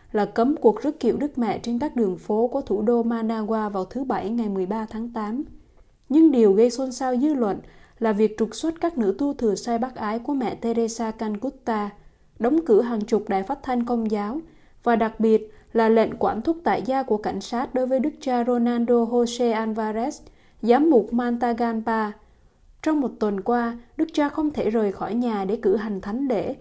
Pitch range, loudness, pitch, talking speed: 220-260 Hz, -23 LUFS, 235 Hz, 205 wpm